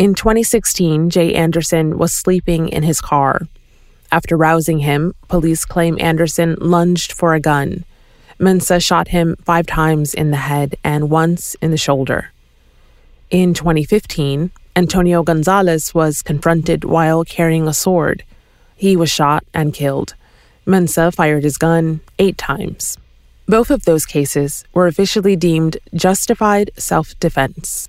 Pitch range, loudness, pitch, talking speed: 155-180 Hz, -15 LUFS, 165 Hz, 135 wpm